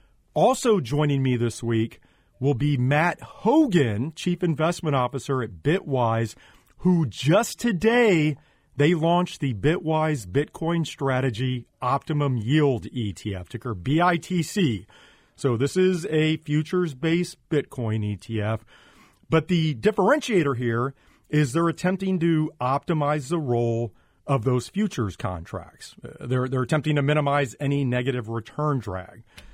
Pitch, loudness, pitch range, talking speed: 145 Hz, -24 LUFS, 120-165 Hz, 120 wpm